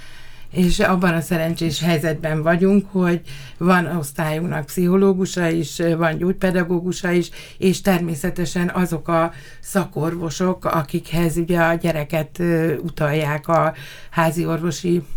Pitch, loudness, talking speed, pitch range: 170 Hz, -20 LUFS, 105 wpm, 160-180 Hz